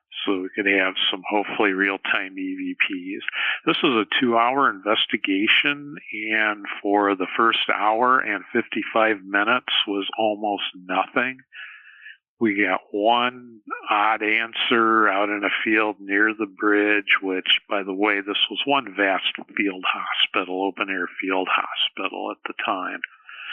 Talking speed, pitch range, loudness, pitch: 135 wpm, 100-115 Hz, -21 LUFS, 105 Hz